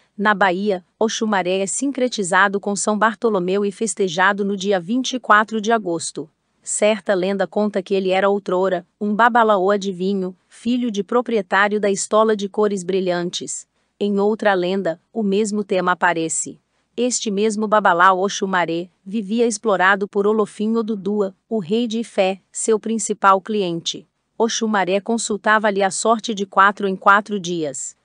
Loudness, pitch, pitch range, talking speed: -19 LUFS, 205 Hz, 190-220 Hz, 140 wpm